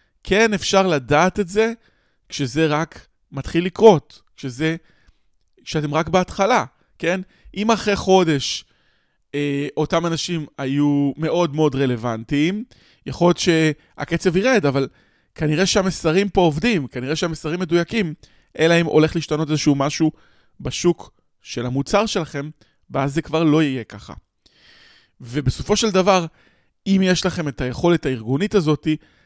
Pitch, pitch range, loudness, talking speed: 160 Hz, 145-185 Hz, -19 LUFS, 125 wpm